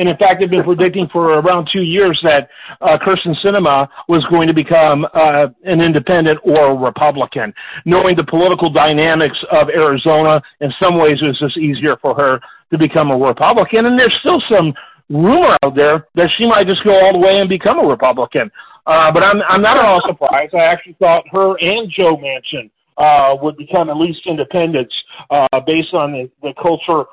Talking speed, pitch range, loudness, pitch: 195 wpm, 150-185 Hz, -12 LUFS, 165 Hz